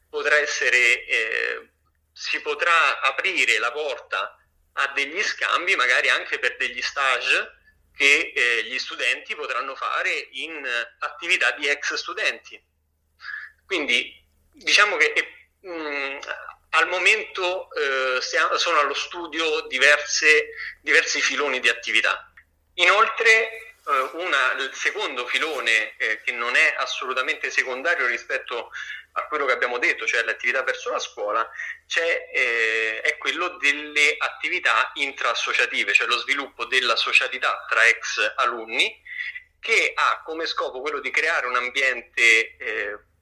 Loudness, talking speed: -21 LUFS, 130 wpm